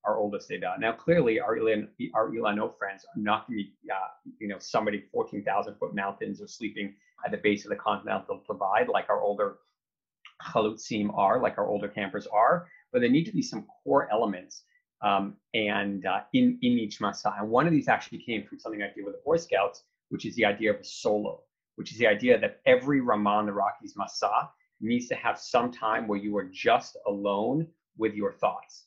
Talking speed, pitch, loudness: 210 wpm, 110 Hz, -28 LUFS